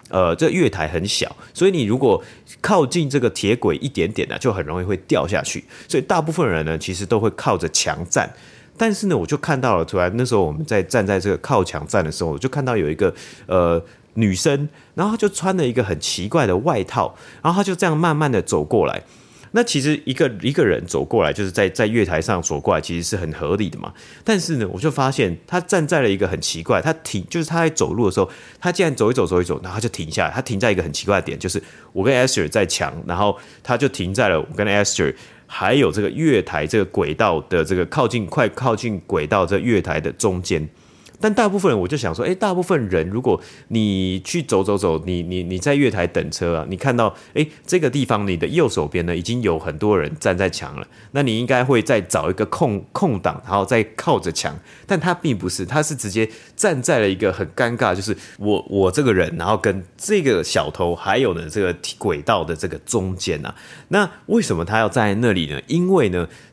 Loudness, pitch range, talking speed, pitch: -20 LUFS, 95-155 Hz, 330 characters per minute, 115 Hz